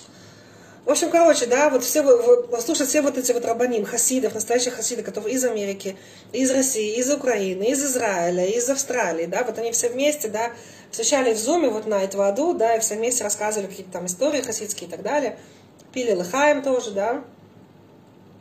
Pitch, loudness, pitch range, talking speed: 240 Hz, -21 LUFS, 215-275 Hz, 185 wpm